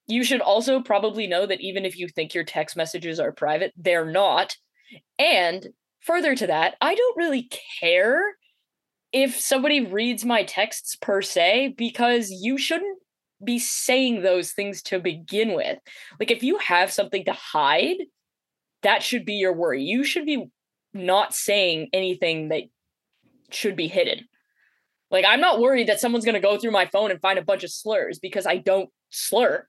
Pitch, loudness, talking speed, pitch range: 205 Hz, -22 LUFS, 175 wpm, 185-255 Hz